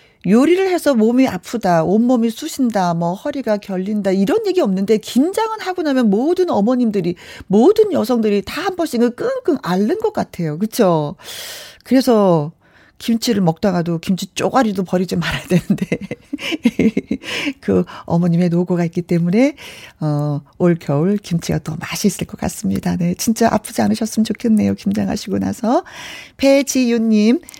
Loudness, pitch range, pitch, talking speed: -17 LUFS, 180-255 Hz, 215 Hz, 315 characters per minute